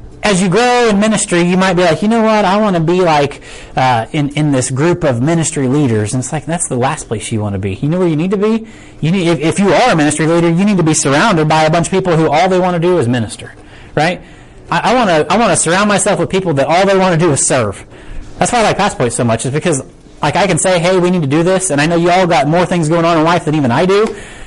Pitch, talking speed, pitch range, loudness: 170 Hz, 305 wpm, 145-185 Hz, -12 LUFS